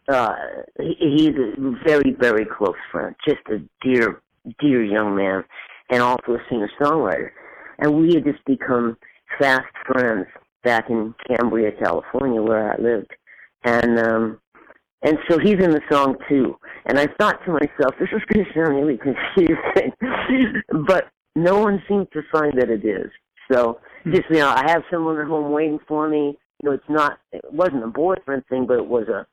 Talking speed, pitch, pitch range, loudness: 180 wpm, 145 Hz, 120-160 Hz, -20 LUFS